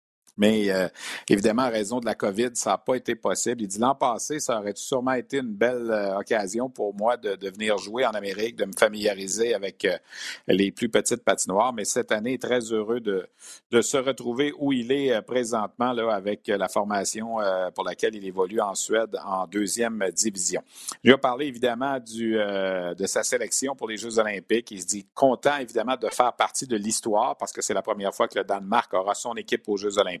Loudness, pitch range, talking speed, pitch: -25 LUFS, 100-125 Hz, 215 wpm, 110 Hz